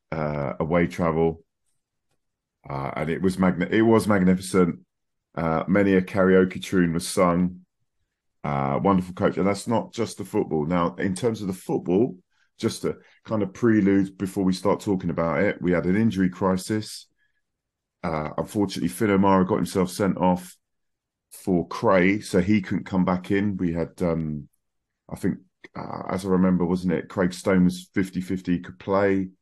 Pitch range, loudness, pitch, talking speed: 85-95 Hz, -24 LUFS, 95 Hz, 170 wpm